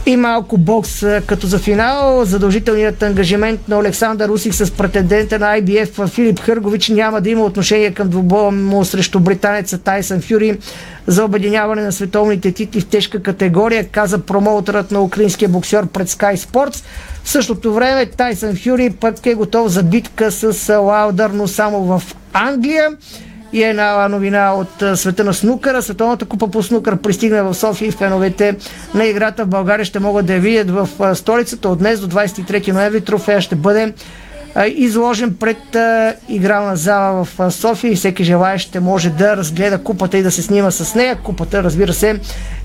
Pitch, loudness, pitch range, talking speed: 205 Hz, -14 LUFS, 195-220 Hz, 165 wpm